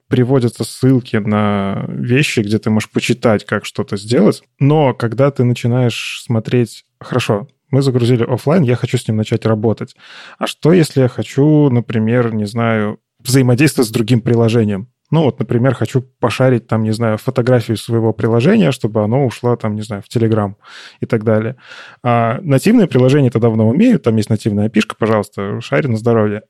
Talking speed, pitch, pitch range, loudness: 170 wpm, 120 Hz, 110-130 Hz, -15 LUFS